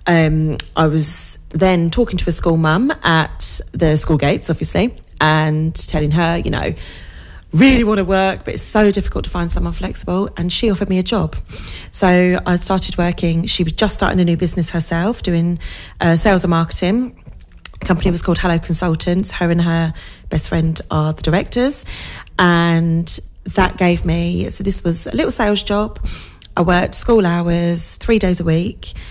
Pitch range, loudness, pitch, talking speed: 160-190 Hz, -16 LUFS, 175 Hz, 180 wpm